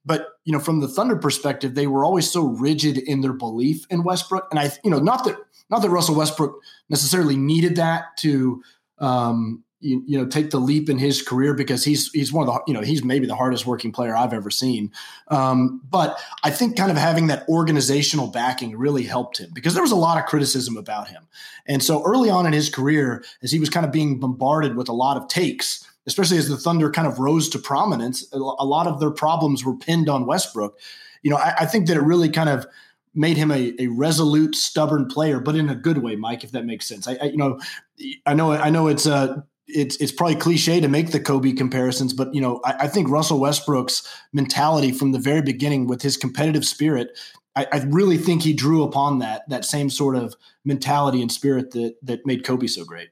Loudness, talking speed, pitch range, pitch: -21 LUFS, 230 wpm, 130-155 Hz, 145 Hz